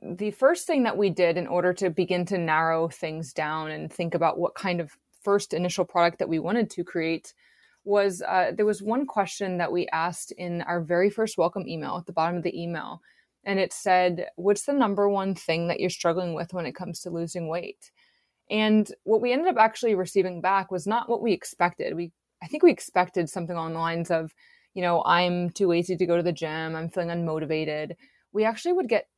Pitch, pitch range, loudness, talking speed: 180 Hz, 170-205 Hz, -26 LUFS, 220 wpm